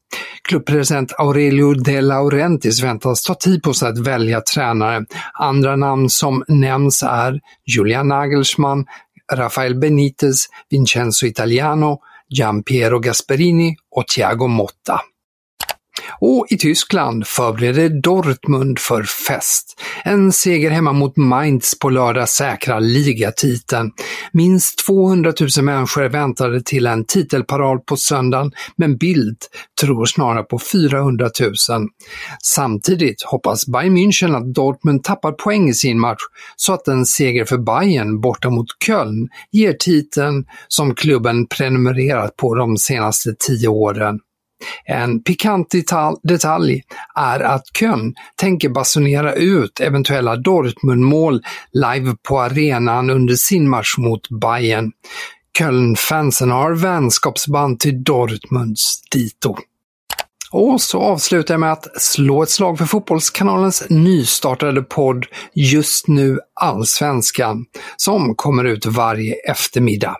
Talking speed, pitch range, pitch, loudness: 120 wpm, 125-155 Hz, 135 Hz, -15 LUFS